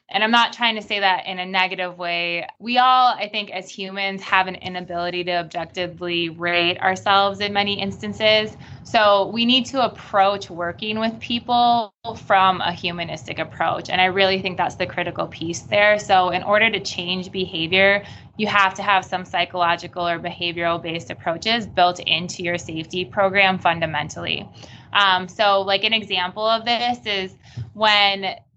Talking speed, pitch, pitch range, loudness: 165 wpm, 190 Hz, 175-205 Hz, -20 LUFS